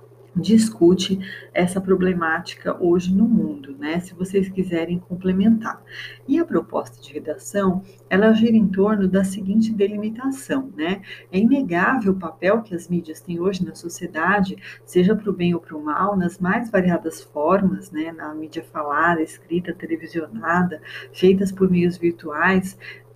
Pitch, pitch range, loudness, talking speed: 185 Hz, 170-200 Hz, -21 LUFS, 150 wpm